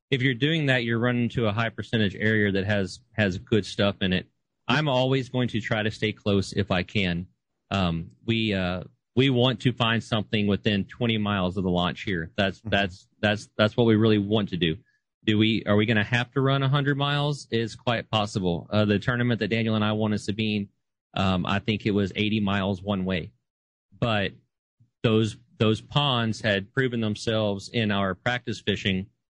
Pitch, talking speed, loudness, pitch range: 110 Hz, 200 wpm, -25 LUFS, 100-120 Hz